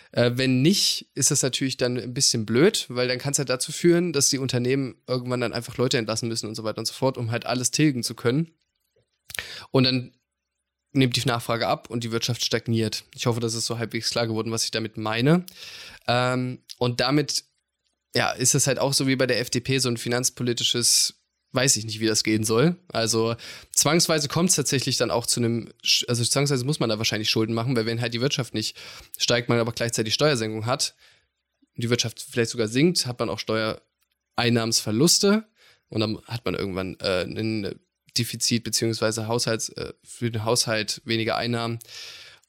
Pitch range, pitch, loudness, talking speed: 115-135 Hz, 120 Hz, -23 LUFS, 195 wpm